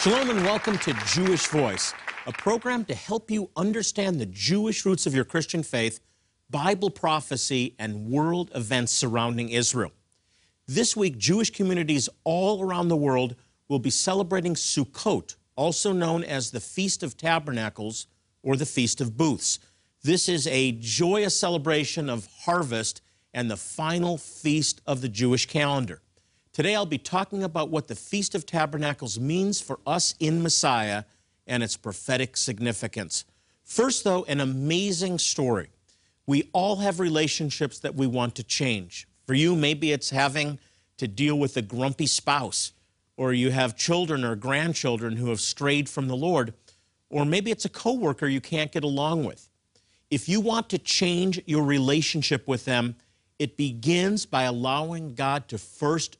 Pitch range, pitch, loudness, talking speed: 115-170 Hz, 145 Hz, -26 LUFS, 155 wpm